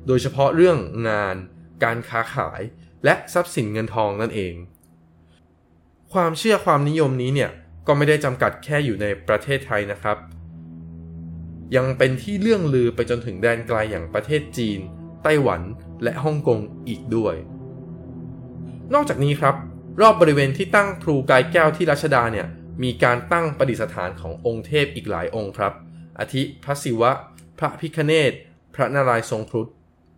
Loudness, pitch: -21 LUFS, 115 Hz